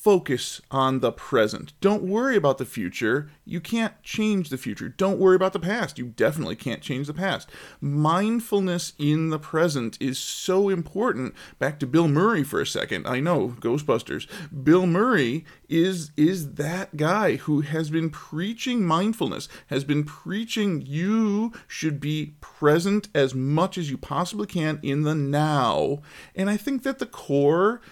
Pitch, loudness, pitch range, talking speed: 165 Hz, -24 LUFS, 150-200 Hz, 160 wpm